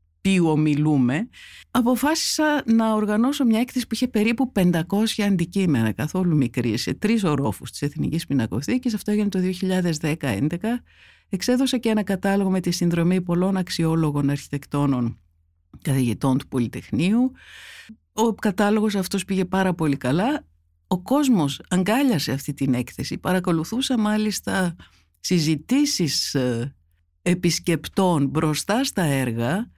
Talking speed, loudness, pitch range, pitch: 115 wpm, -22 LUFS, 140-215 Hz, 180 Hz